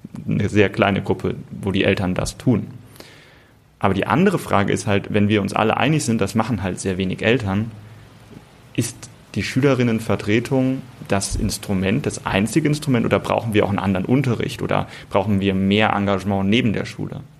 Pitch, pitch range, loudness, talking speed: 105 Hz, 100-120 Hz, -20 LUFS, 170 wpm